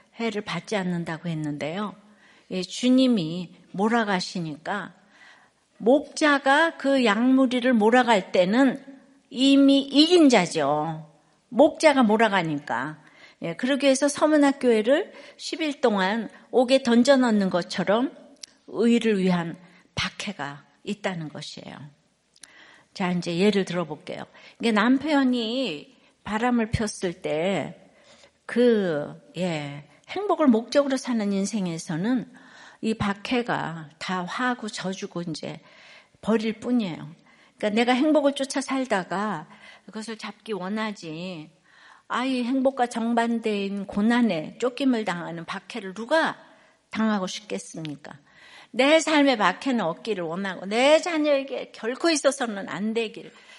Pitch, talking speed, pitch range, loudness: 220 Hz, 250 characters per minute, 185-265 Hz, -24 LUFS